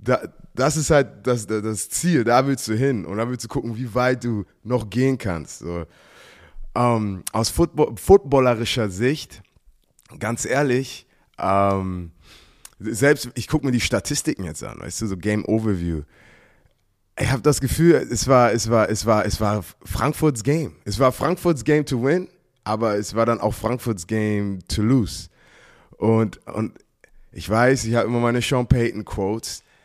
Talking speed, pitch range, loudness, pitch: 170 wpm, 105-130 Hz, -21 LUFS, 115 Hz